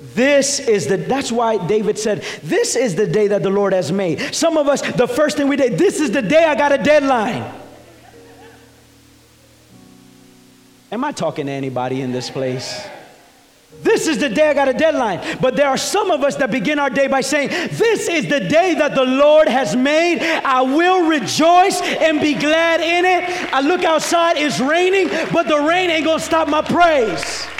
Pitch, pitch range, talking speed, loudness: 290 Hz, 235-325 Hz, 195 wpm, -16 LUFS